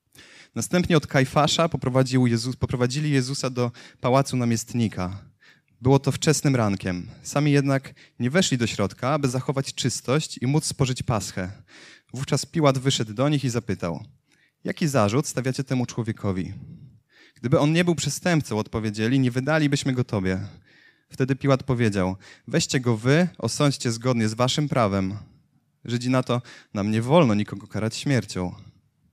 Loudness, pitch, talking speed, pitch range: -24 LUFS, 130 Hz, 140 wpm, 115-145 Hz